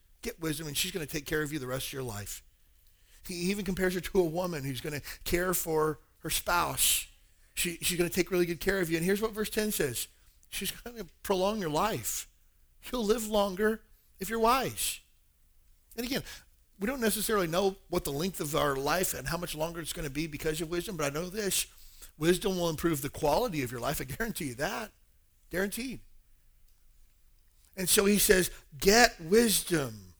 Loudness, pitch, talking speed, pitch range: -30 LUFS, 170 Hz, 205 wpm, 130-195 Hz